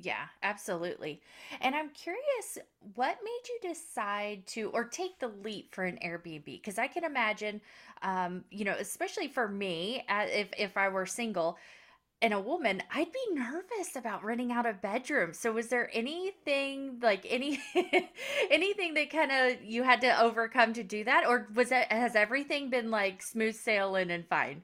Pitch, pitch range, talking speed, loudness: 240 Hz, 210-300 Hz, 175 wpm, -32 LUFS